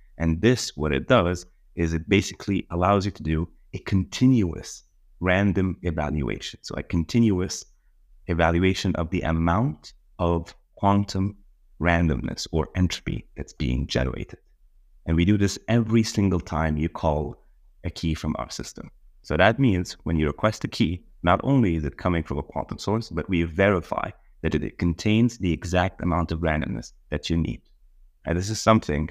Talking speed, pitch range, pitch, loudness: 165 wpm, 80-100 Hz, 85 Hz, -24 LUFS